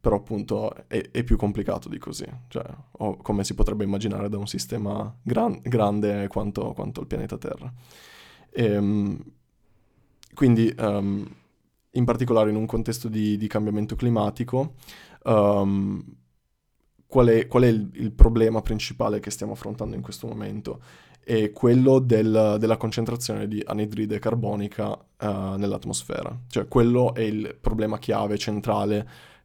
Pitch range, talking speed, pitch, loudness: 105-115 Hz, 140 wpm, 105 Hz, -25 LUFS